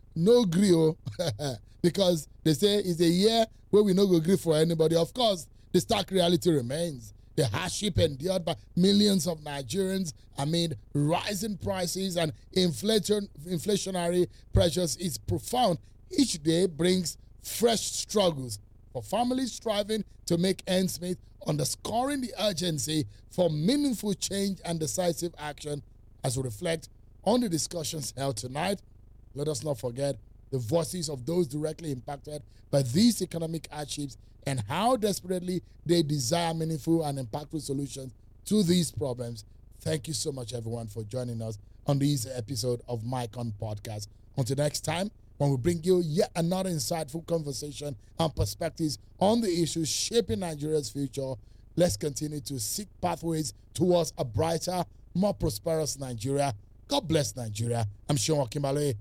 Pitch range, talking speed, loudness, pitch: 130-180 Hz, 145 wpm, -29 LUFS, 155 Hz